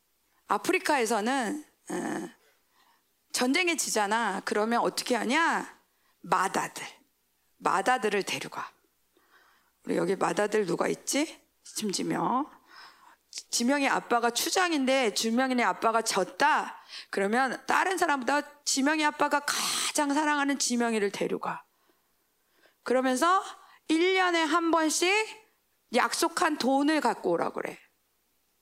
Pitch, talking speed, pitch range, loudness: 285 Hz, 245 characters per minute, 235-330 Hz, -27 LUFS